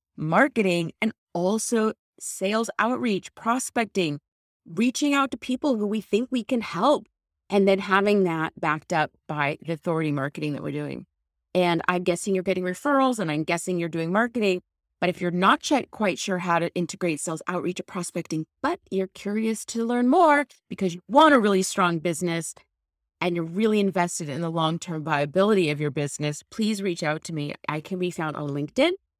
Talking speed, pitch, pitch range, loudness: 185 wpm, 180 Hz, 160-220 Hz, -25 LUFS